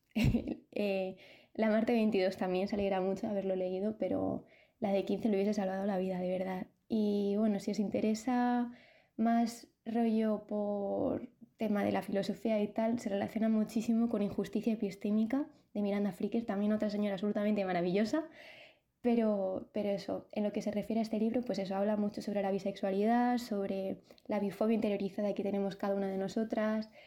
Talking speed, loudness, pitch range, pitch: 170 wpm, -34 LUFS, 200-225 Hz, 210 Hz